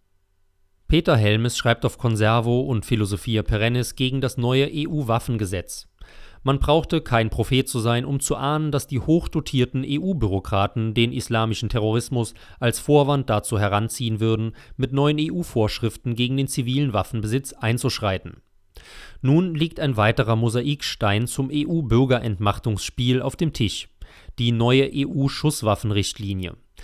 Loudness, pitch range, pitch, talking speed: -22 LUFS, 110-140 Hz, 120 Hz, 120 wpm